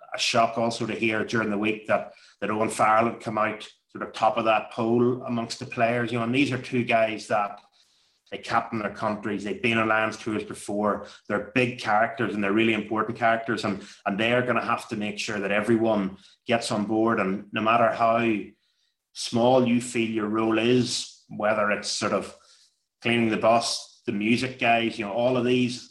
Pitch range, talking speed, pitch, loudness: 110-120 Hz, 210 wpm, 115 Hz, -25 LUFS